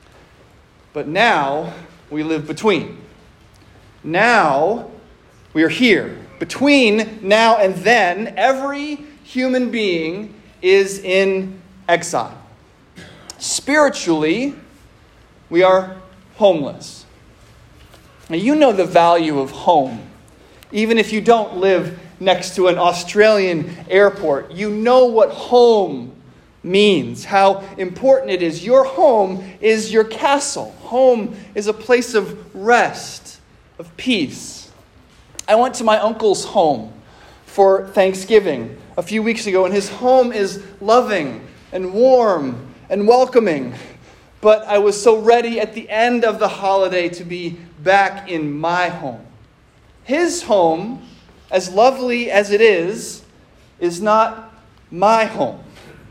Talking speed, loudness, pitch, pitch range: 120 wpm, -16 LUFS, 210 Hz, 185-240 Hz